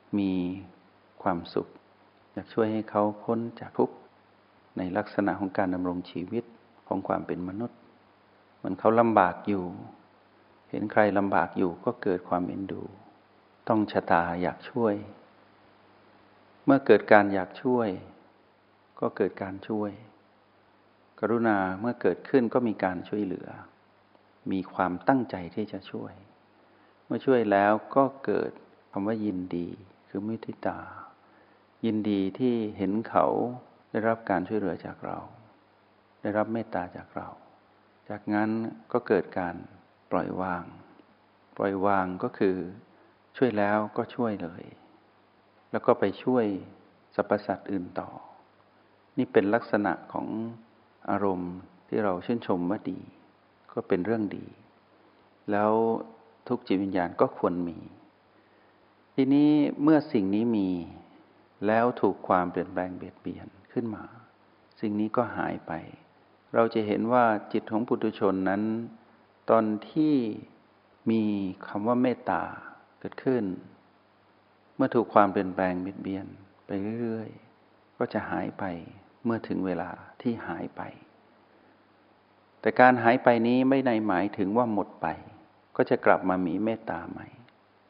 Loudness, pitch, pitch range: -28 LUFS, 105 Hz, 95-115 Hz